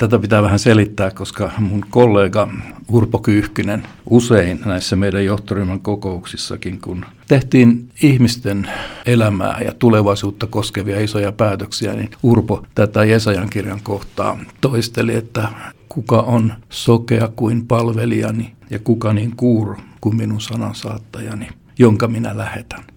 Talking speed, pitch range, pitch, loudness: 120 wpm, 100-115 Hz, 110 Hz, -16 LUFS